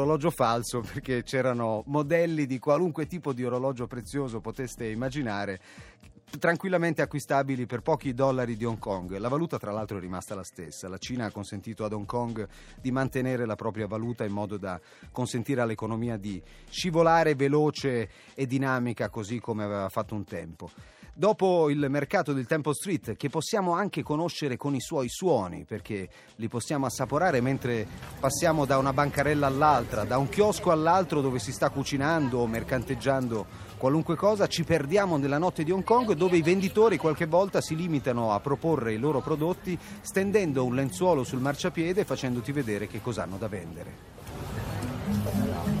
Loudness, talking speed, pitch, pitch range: -28 LUFS, 160 wpm, 130 Hz, 110-155 Hz